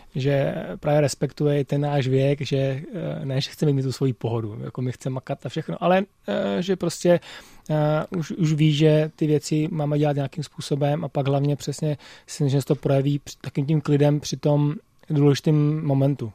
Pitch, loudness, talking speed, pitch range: 145 Hz, -23 LUFS, 180 wpm, 140-155 Hz